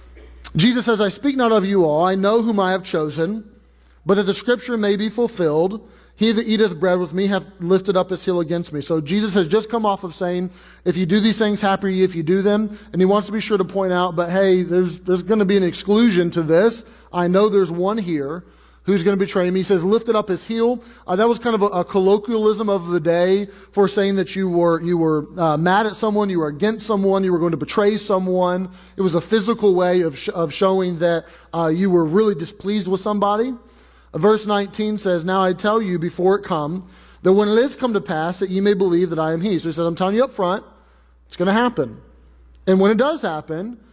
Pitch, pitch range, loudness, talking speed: 190 Hz, 175-210 Hz, -19 LUFS, 245 wpm